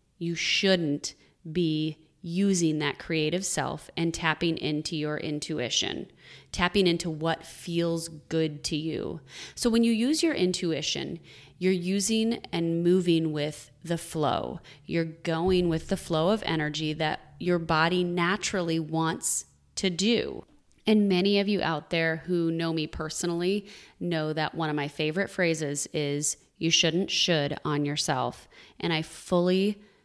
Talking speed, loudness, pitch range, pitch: 145 wpm, -27 LUFS, 155-180 Hz, 165 Hz